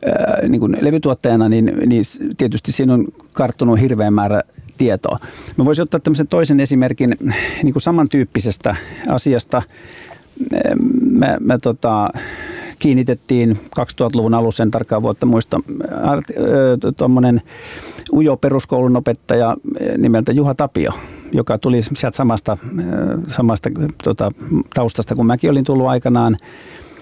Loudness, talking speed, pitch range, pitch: -16 LUFS, 105 wpm, 115-145 Hz, 125 Hz